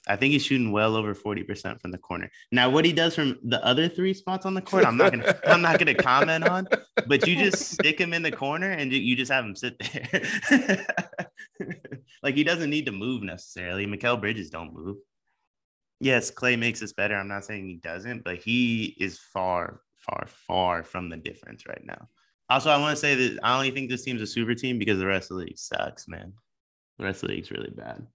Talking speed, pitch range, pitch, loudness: 220 wpm, 100-150 Hz, 125 Hz, -25 LUFS